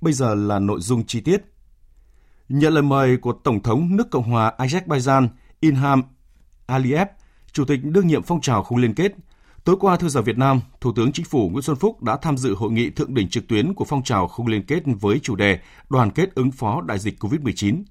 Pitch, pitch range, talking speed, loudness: 130 Hz, 110-150 Hz, 220 wpm, -20 LUFS